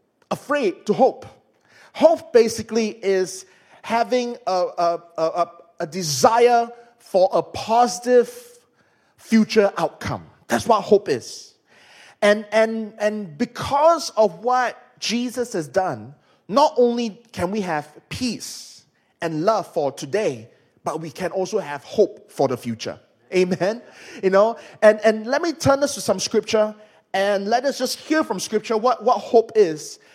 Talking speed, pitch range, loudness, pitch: 145 wpm, 185-245 Hz, -21 LUFS, 215 Hz